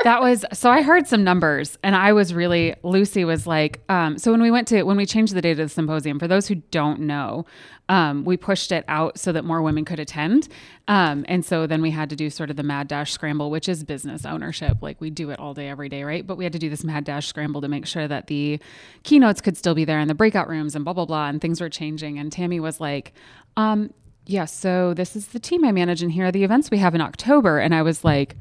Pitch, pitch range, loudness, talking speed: 165 Hz, 150-190 Hz, -21 LUFS, 270 wpm